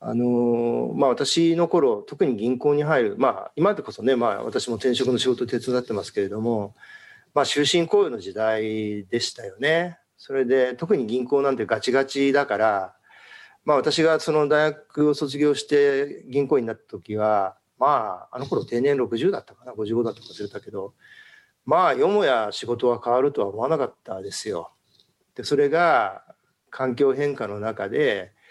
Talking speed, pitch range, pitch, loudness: 310 characters per minute, 120-150 Hz, 130 Hz, -23 LUFS